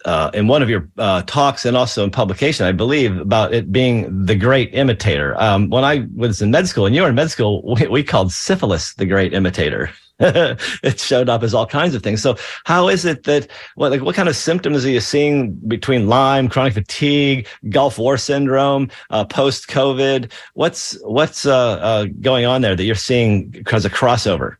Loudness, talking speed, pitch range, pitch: -16 LUFS, 205 wpm, 105-135 Hz, 120 Hz